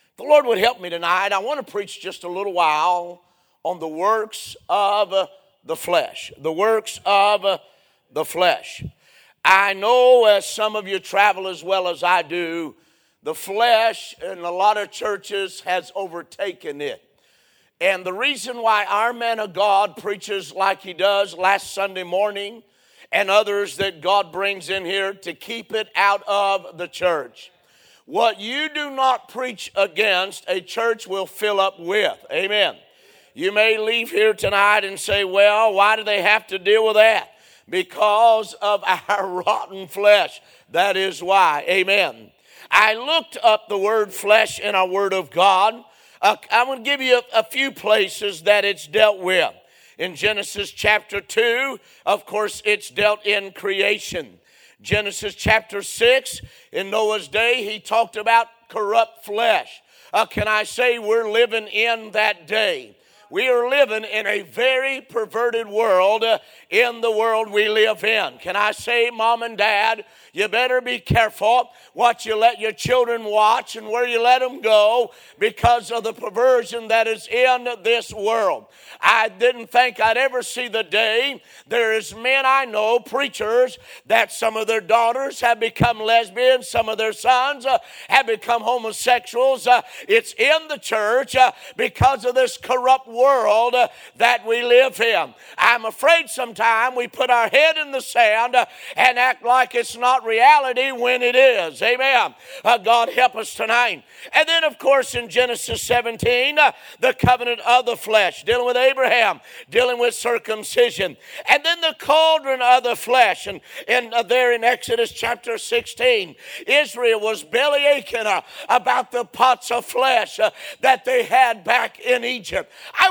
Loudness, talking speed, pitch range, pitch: -19 LUFS, 165 wpm, 205-250 Hz, 225 Hz